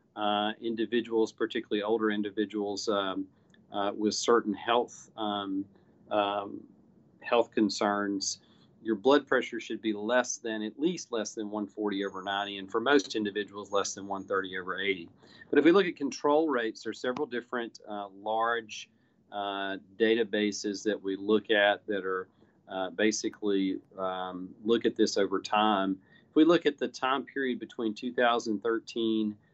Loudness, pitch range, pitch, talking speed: -30 LUFS, 100-115 Hz, 105 Hz, 150 wpm